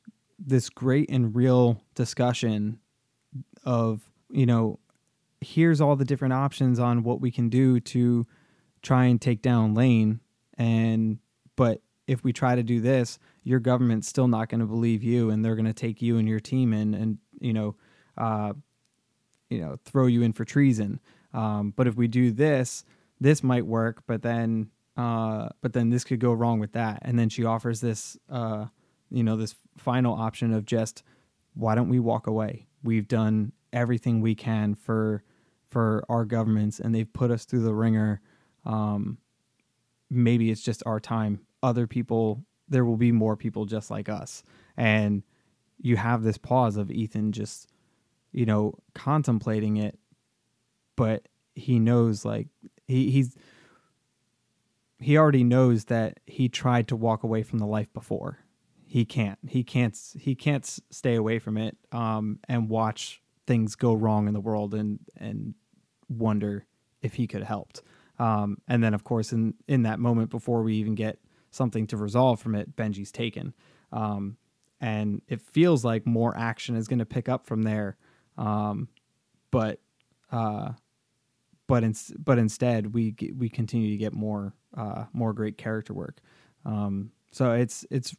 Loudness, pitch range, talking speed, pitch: -26 LUFS, 110-125 Hz, 165 wpm, 115 Hz